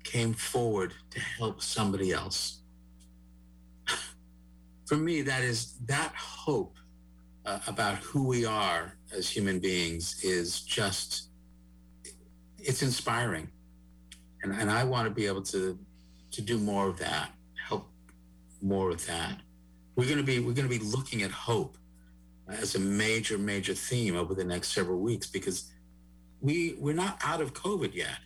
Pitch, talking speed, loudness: 90 Hz, 150 wpm, -32 LUFS